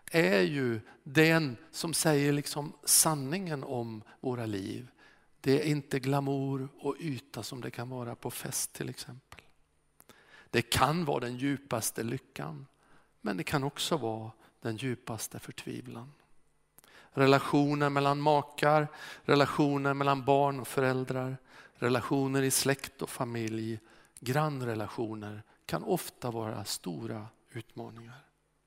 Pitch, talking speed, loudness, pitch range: 135 Hz, 120 wpm, -31 LUFS, 120-145 Hz